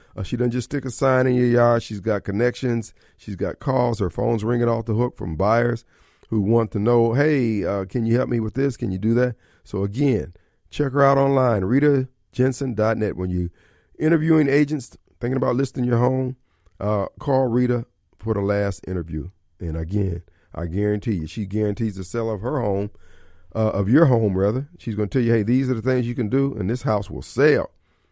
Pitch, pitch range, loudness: 115 Hz, 100-125 Hz, -22 LUFS